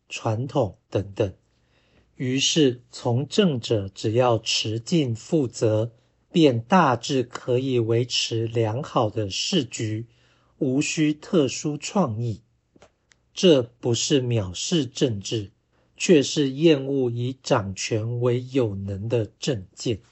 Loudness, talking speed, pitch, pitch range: -23 LUFS, 160 characters per minute, 120 Hz, 115-140 Hz